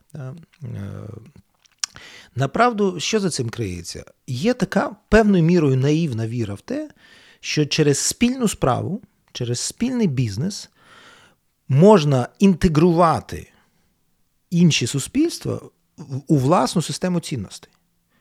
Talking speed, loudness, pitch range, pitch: 90 wpm, -19 LUFS, 130-200 Hz, 165 Hz